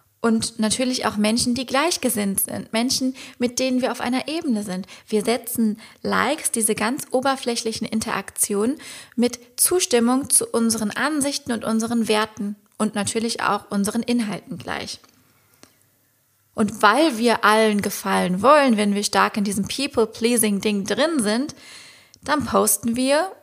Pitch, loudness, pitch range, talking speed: 230 Hz, -21 LUFS, 215-255 Hz, 135 wpm